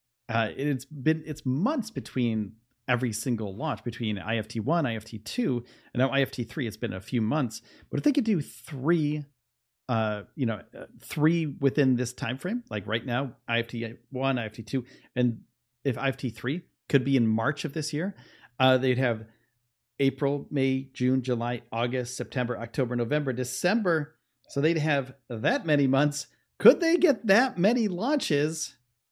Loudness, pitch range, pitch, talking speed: -28 LUFS, 120-150 Hz, 130 Hz, 165 wpm